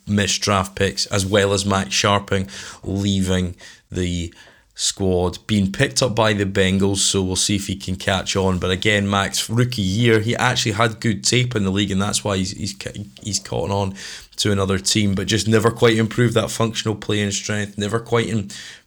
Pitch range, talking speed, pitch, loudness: 95-110 Hz, 195 wpm, 100 Hz, -19 LUFS